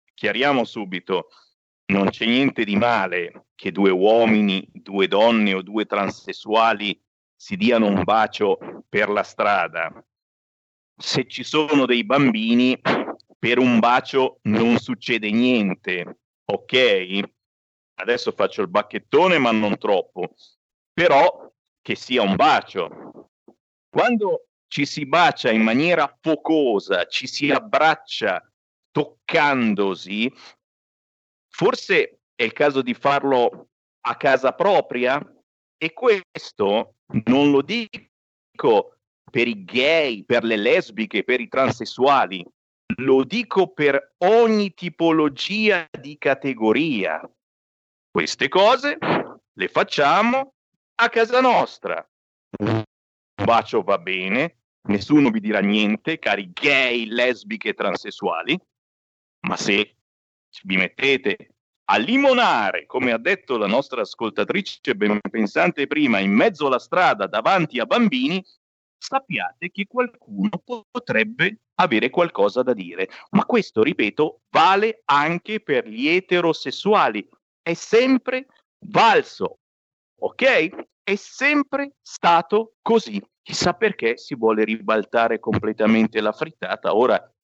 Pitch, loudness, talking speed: 140 Hz, -20 LUFS, 110 wpm